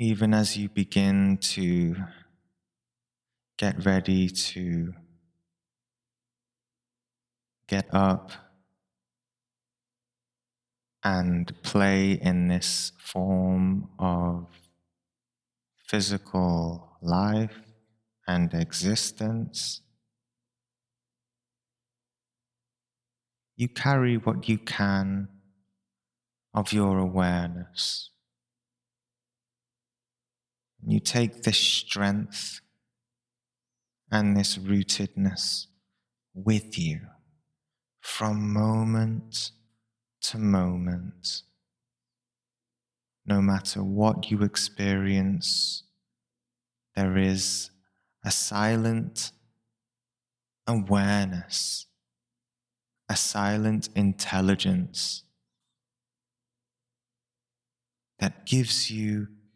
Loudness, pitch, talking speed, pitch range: -26 LUFS, 110 Hz, 55 wpm, 95-120 Hz